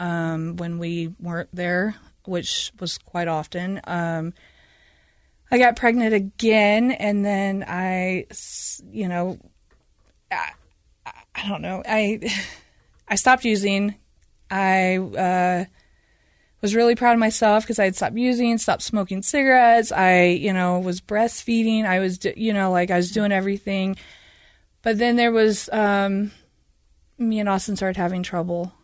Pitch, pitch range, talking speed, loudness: 195 Hz, 180-220 Hz, 140 wpm, -21 LUFS